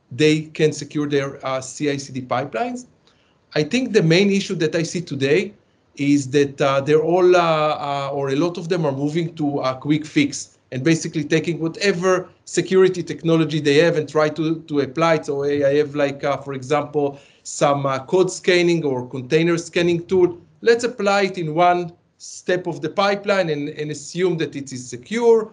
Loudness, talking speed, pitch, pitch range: -20 LUFS, 185 wpm, 155 Hz, 145-175 Hz